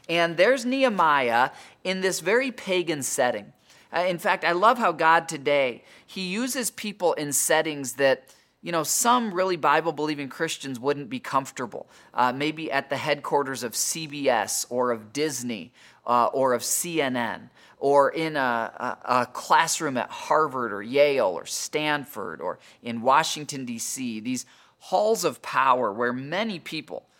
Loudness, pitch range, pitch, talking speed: -24 LUFS, 135-185 Hz, 155 Hz, 150 wpm